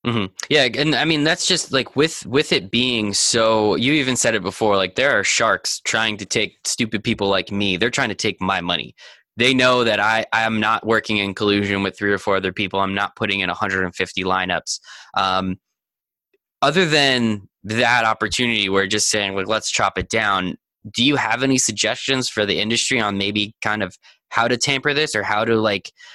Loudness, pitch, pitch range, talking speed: -19 LUFS, 110 Hz, 100-125 Hz, 210 wpm